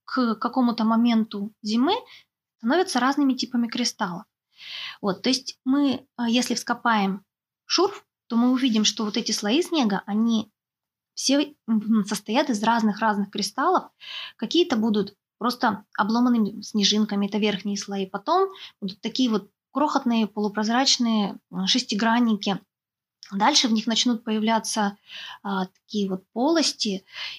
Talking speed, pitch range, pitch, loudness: 120 wpm, 205-255 Hz, 225 Hz, -24 LUFS